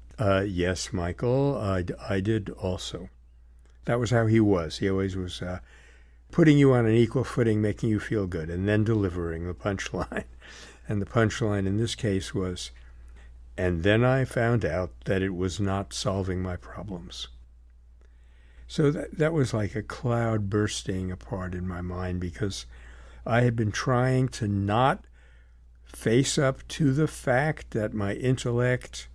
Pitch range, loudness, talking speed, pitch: 70-115 Hz, -27 LUFS, 160 wpm, 95 Hz